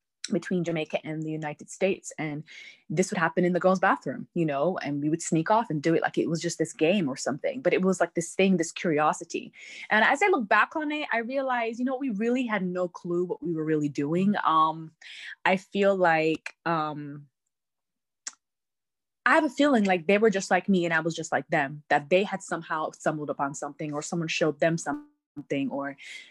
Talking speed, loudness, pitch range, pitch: 215 wpm, -26 LUFS, 155-195 Hz, 170 Hz